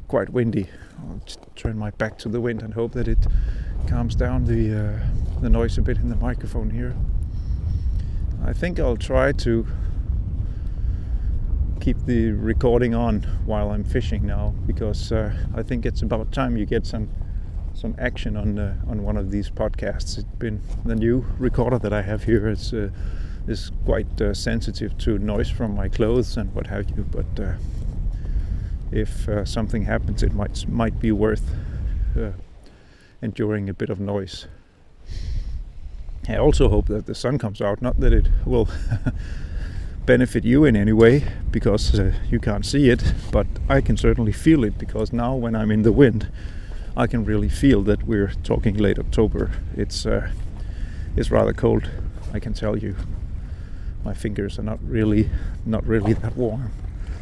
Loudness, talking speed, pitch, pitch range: -23 LUFS, 170 wpm, 105 Hz, 90-115 Hz